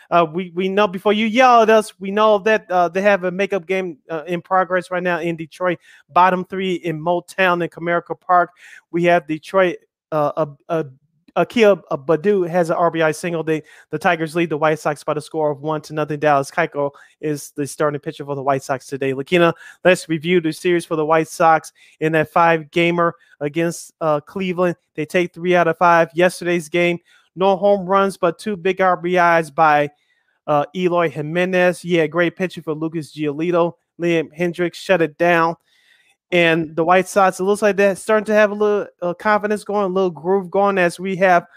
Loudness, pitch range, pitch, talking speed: -18 LUFS, 160-185 Hz, 175 Hz, 200 wpm